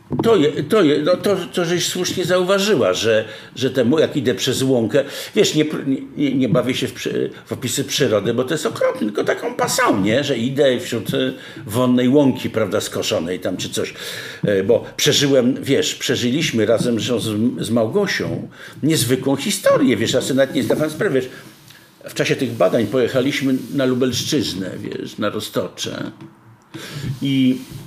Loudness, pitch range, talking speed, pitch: -18 LUFS, 130-175 Hz, 160 wpm, 140 Hz